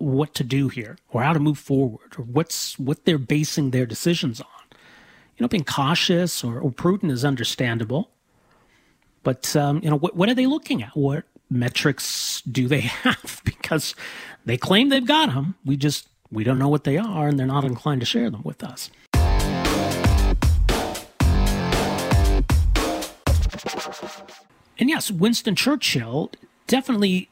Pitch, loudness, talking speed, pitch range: 145 Hz, -22 LUFS, 150 wpm, 125-180 Hz